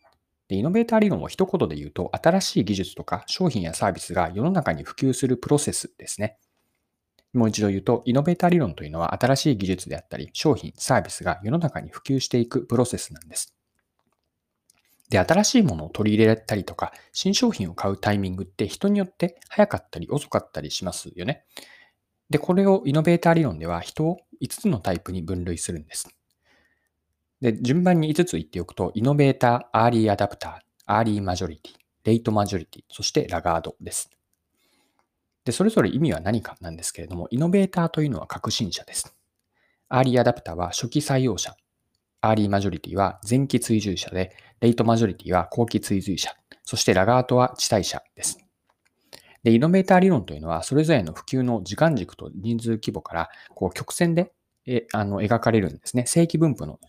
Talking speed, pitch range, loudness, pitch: 400 characters per minute, 95-155 Hz, -23 LUFS, 115 Hz